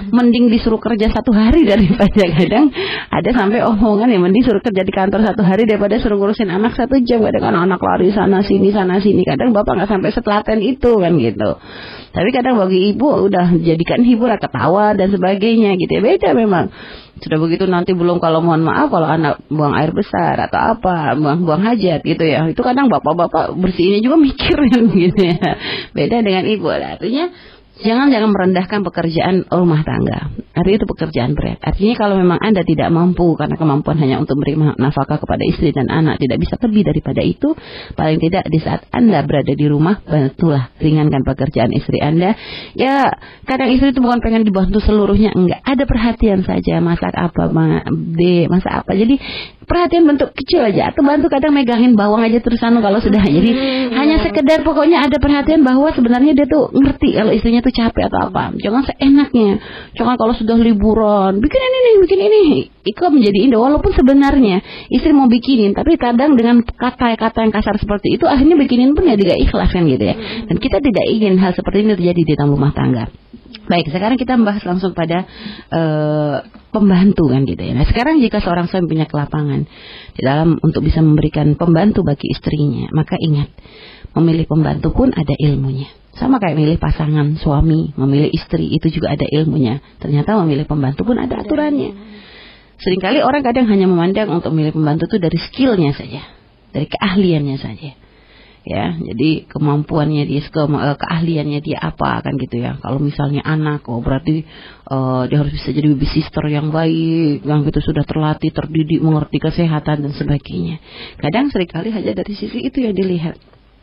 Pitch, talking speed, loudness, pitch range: 190 Hz, 175 wpm, -14 LUFS, 155-235 Hz